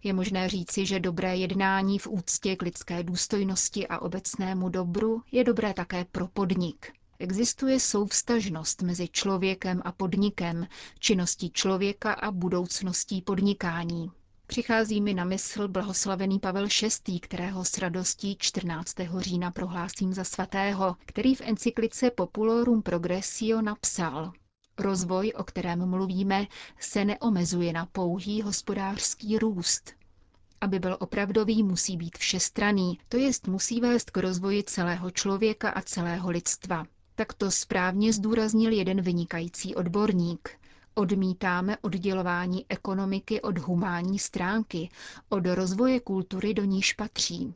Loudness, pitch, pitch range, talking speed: -28 LUFS, 190 Hz, 180-210 Hz, 120 wpm